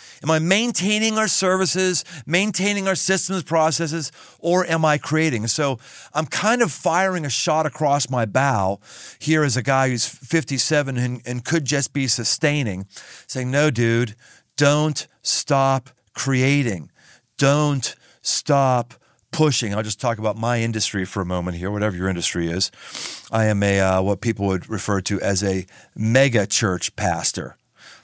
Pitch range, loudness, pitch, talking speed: 110-155 Hz, -20 LUFS, 135 Hz, 155 wpm